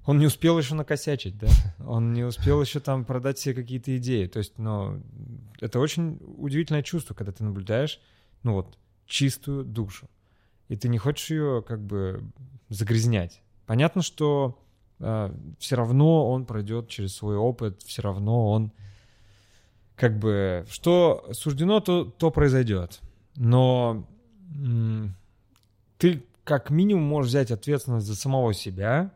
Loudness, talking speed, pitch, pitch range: -25 LUFS, 140 wpm, 120 Hz, 105-145 Hz